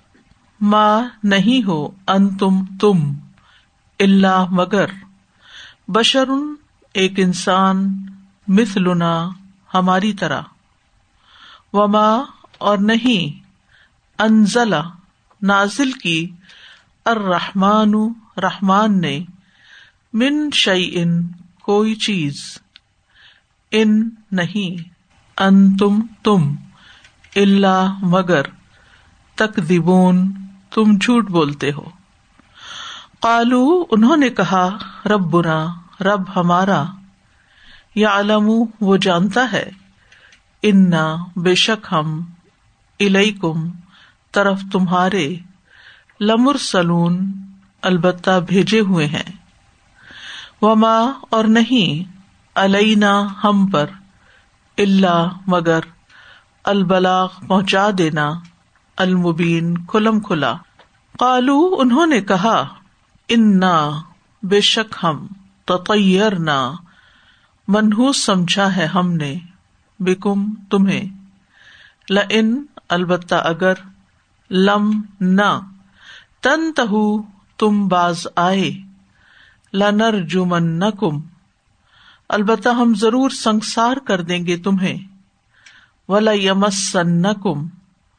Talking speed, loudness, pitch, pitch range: 75 wpm, -16 LUFS, 195 Hz, 180-215 Hz